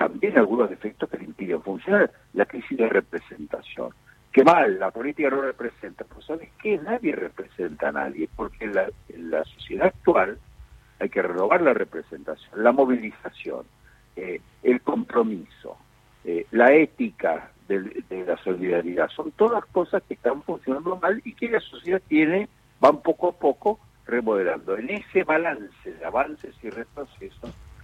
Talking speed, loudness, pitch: 155 wpm, -24 LUFS, 140 Hz